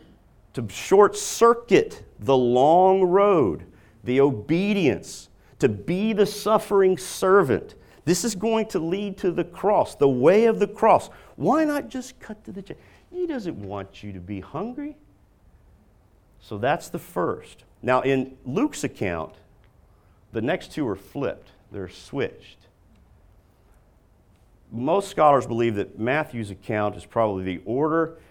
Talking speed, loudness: 135 wpm, -22 LUFS